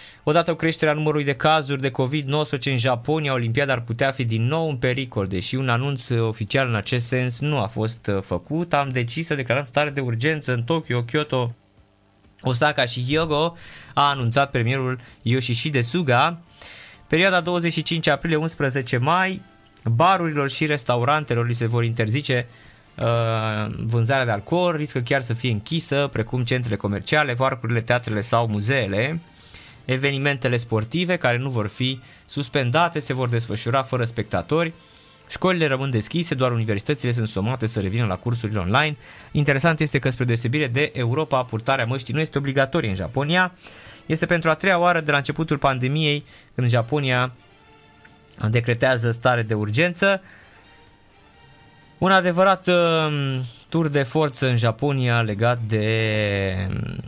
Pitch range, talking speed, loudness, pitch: 115-150 Hz, 145 wpm, -22 LUFS, 130 Hz